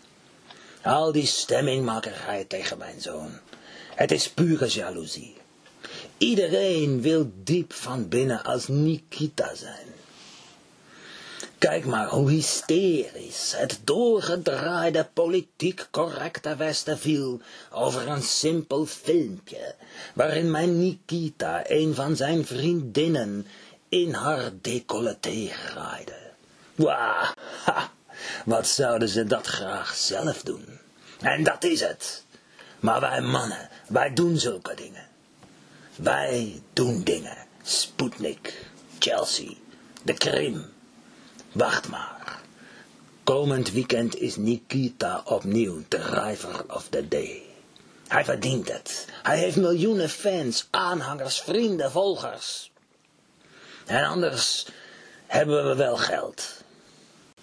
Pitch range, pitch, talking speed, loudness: 130-175 Hz, 155 Hz, 100 wpm, -26 LUFS